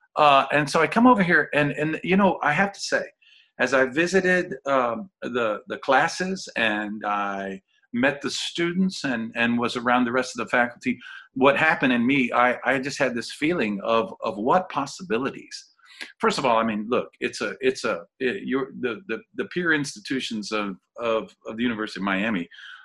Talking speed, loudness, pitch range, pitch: 195 wpm, -23 LUFS, 115-190 Hz, 140 Hz